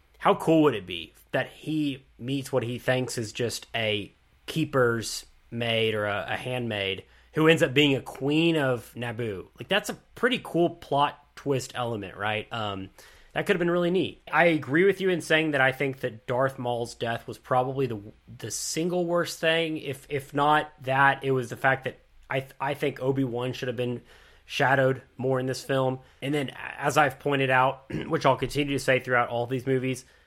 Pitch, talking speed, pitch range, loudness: 130 Hz, 200 wpm, 120-150 Hz, -26 LUFS